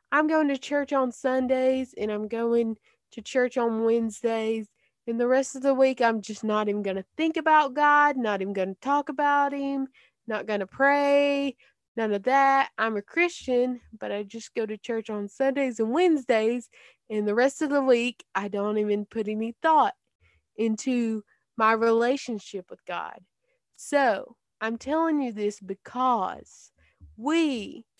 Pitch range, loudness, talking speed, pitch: 220-275 Hz, -26 LUFS, 170 wpm, 240 Hz